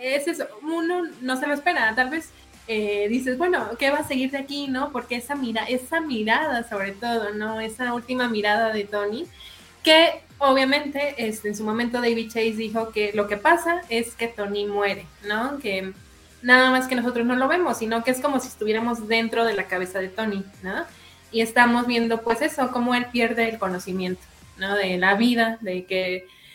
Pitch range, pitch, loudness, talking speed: 210-260 Hz, 230 Hz, -23 LUFS, 195 wpm